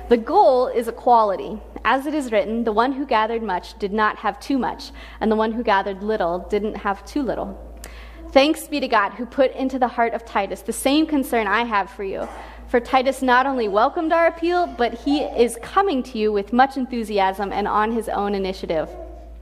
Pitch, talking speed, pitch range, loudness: 235 Hz, 205 wpm, 210-265 Hz, -21 LUFS